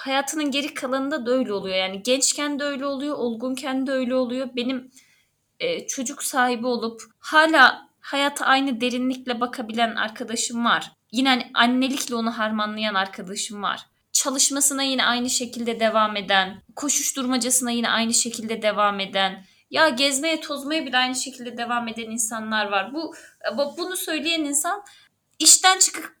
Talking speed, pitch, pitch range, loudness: 140 wpm, 255 Hz, 230-285 Hz, -22 LUFS